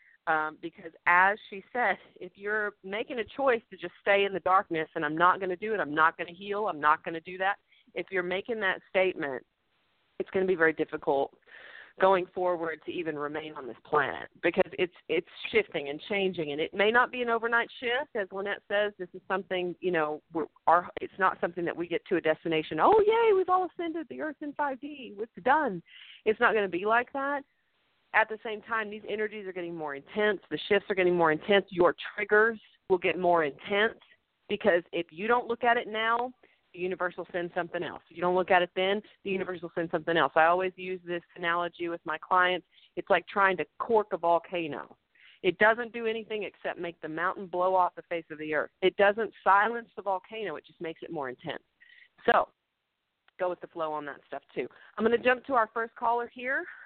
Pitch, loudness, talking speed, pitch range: 190 Hz, -29 LUFS, 225 wpm, 175-225 Hz